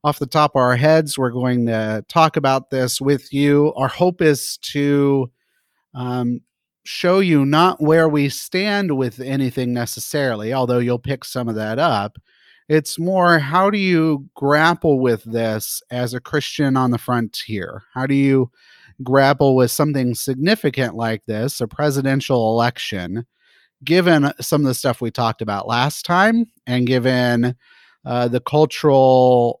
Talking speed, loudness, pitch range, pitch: 155 wpm, -18 LUFS, 125-150 Hz, 135 Hz